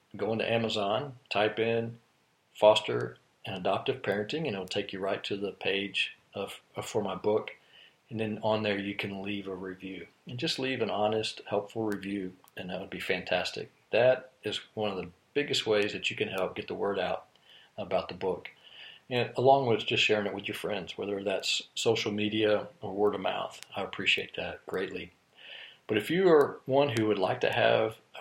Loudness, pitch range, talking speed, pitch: -30 LUFS, 100-115 Hz, 195 wpm, 105 Hz